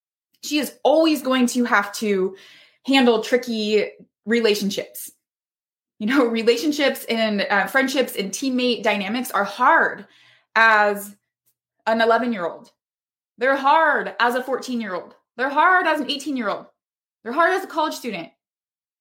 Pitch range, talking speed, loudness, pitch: 205-270 Hz, 145 wpm, -20 LUFS, 235 Hz